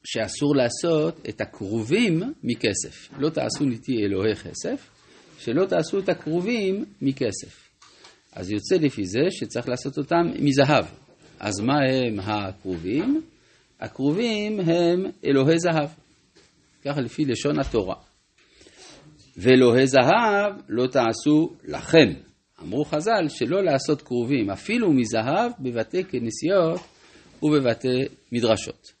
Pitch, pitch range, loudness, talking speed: 135 Hz, 115-160 Hz, -23 LUFS, 105 wpm